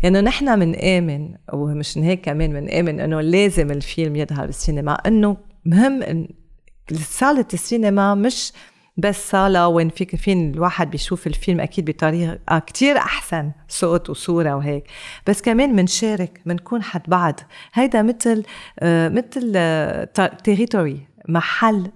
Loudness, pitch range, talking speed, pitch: -19 LUFS, 160-205 Hz, 130 wpm, 180 Hz